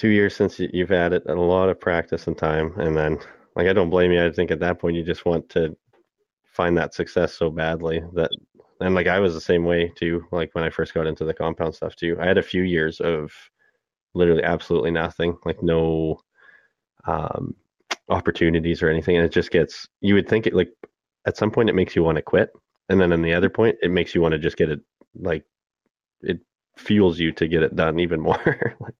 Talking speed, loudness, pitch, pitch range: 230 wpm, -22 LUFS, 85 Hz, 80-90 Hz